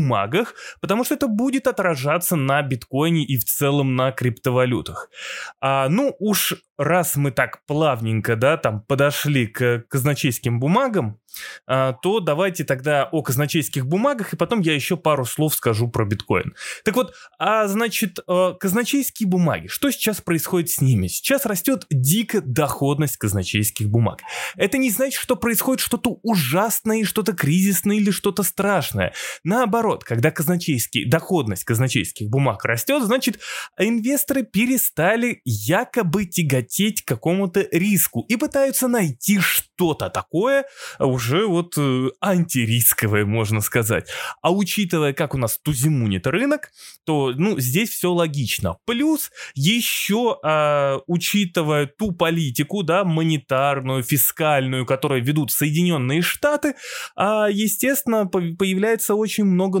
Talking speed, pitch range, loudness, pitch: 125 wpm, 135-210 Hz, -20 LUFS, 170 Hz